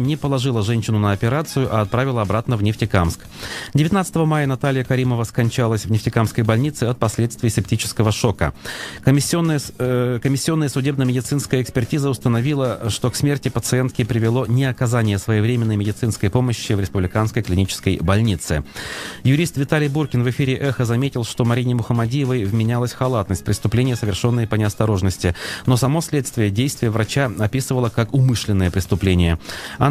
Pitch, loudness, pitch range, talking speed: 120 Hz, -19 LUFS, 110-130 Hz, 135 wpm